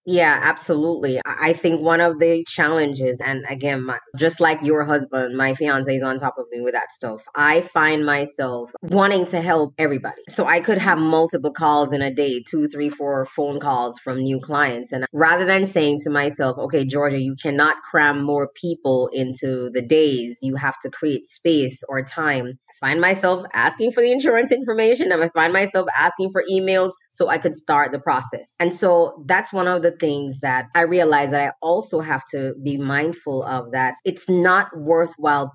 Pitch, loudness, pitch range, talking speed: 150 Hz, -19 LUFS, 135-170 Hz, 190 wpm